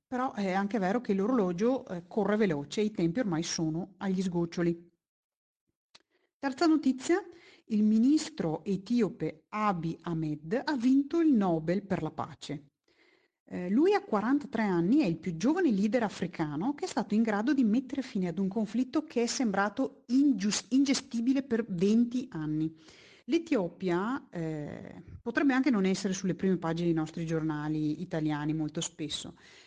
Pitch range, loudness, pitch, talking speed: 170-260 Hz, -30 LUFS, 205 Hz, 150 wpm